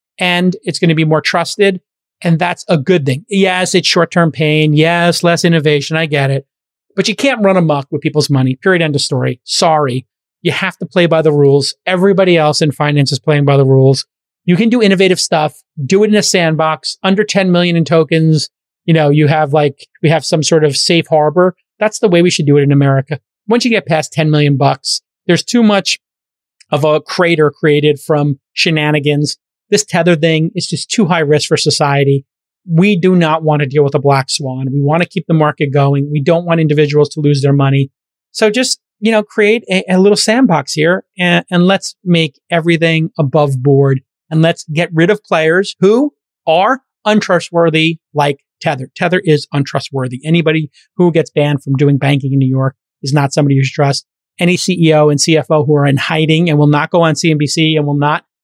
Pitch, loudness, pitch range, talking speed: 160 Hz, -12 LUFS, 145-180 Hz, 205 wpm